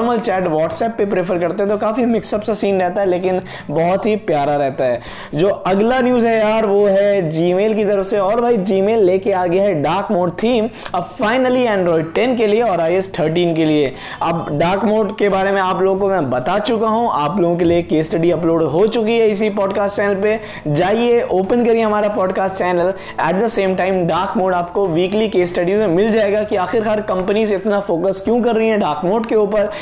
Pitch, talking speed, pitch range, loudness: 200 Hz, 220 wpm, 180-220 Hz, -16 LUFS